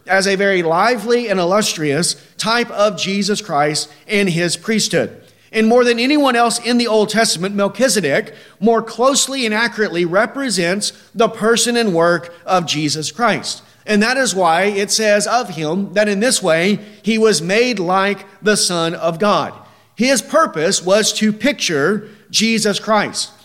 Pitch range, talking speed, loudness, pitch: 185-230 Hz, 160 wpm, -16 LUFS, 210 Hz